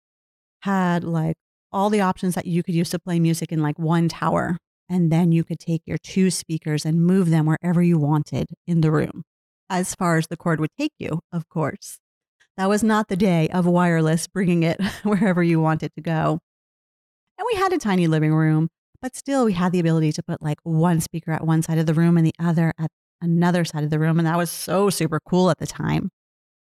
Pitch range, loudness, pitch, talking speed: 160-180 Hz, -21 LUFS, 170 Hz, 220 wpm